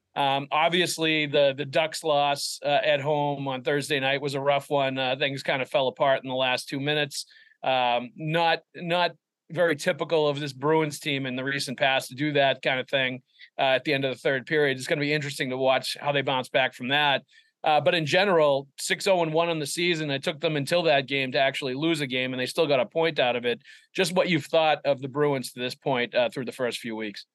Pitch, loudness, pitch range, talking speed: 145 Hz, -25 LUFS, 135-160 Hz, 250 wpm